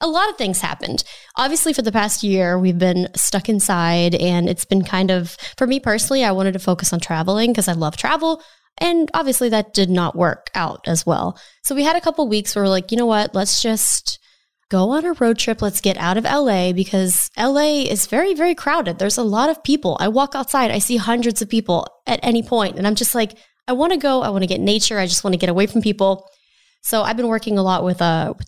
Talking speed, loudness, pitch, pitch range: 255 wpm, -18 LUFS, 215 Hz, 190-260 Hz